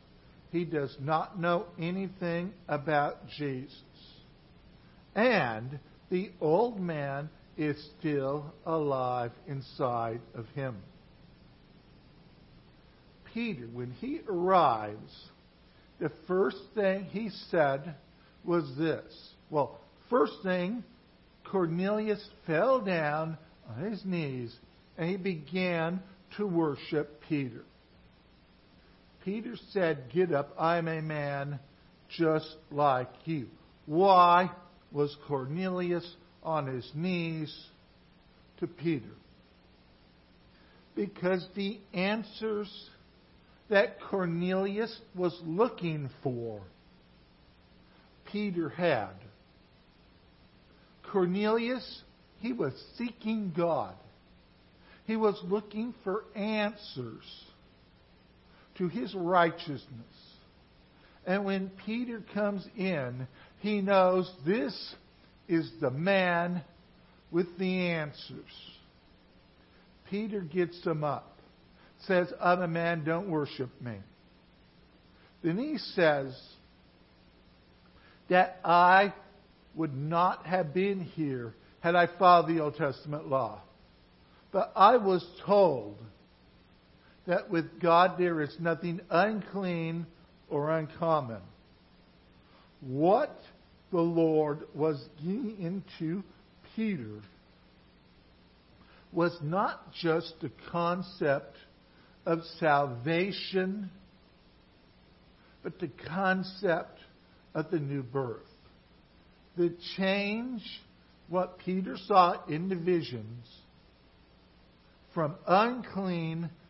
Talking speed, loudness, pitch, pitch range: 85 wpm, -31 LUFS, 170 Hz, 145-190 Hz